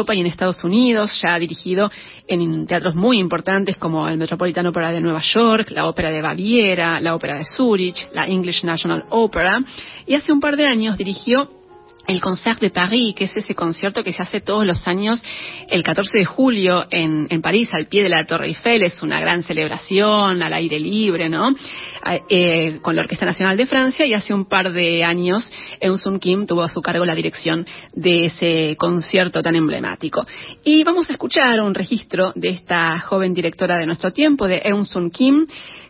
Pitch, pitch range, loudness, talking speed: 185 Hz, 170-215 Hz, -18 LUFS, 195 wpm